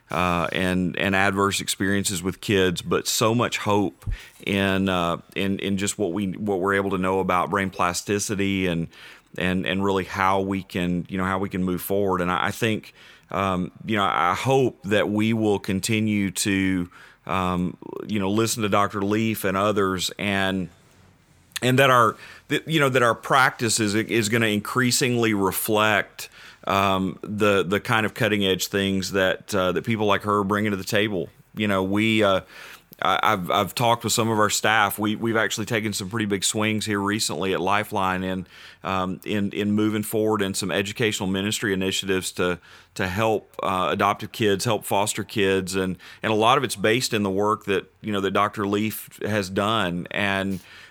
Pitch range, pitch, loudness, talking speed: 95-105 Hz, 100 Hz, -23 LUFS, 190 wpm